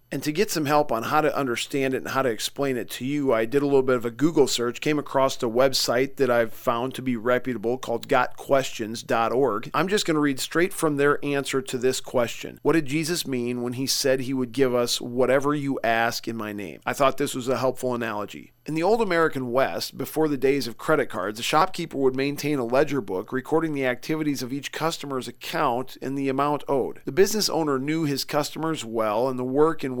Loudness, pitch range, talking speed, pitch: -24 LUFS, 125-150 Hz, 230 wpm, 135 Hz